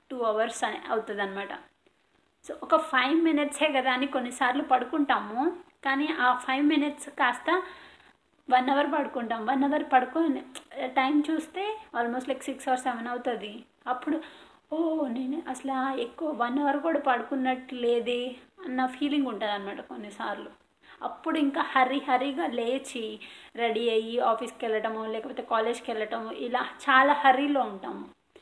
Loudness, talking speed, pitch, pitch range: -28 LUFS, 130 wpm, 260 Hz, 240-295 Hz